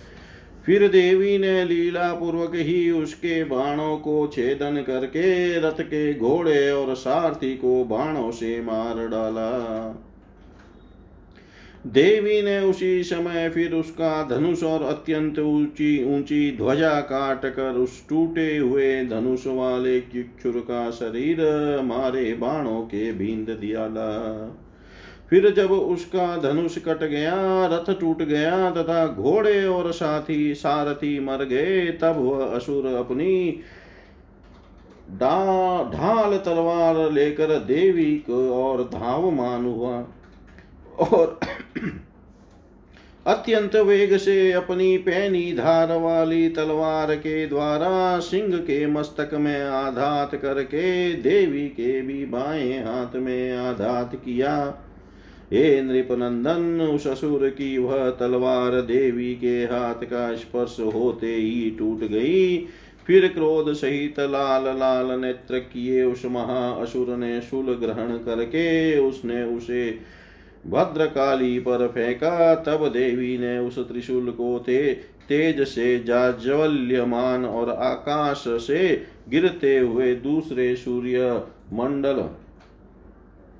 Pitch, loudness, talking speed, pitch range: 140 Hz, -22 LUFS, 110 wpm, 125-165 Hz